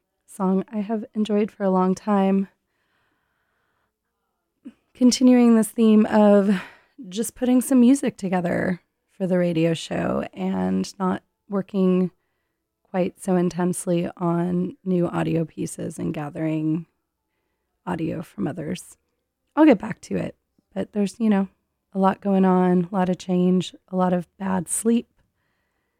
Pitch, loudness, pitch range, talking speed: 190 Hz, -22 LUFS, 180-215 Hz, 135 wpm